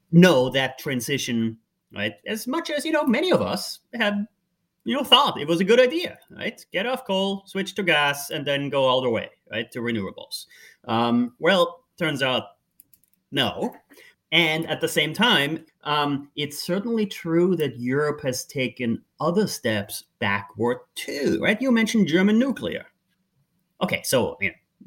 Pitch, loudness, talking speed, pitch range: 160 Hz, -23 LUFS, 165 wpm, 130-195 Hz